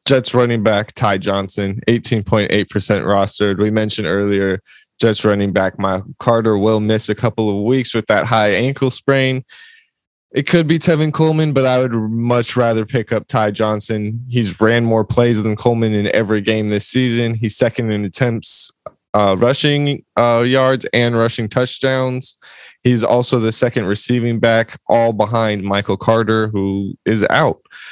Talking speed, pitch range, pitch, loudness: 170 wpm, 105-125 Hz, 115 Hz, -16 LUFS